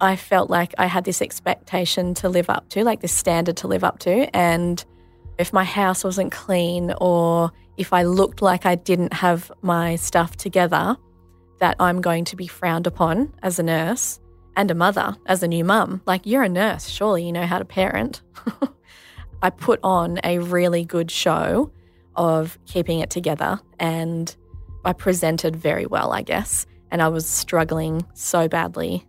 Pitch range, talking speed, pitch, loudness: 165-185 Hz, 175 wpm, 175 Hz, -21 LUFS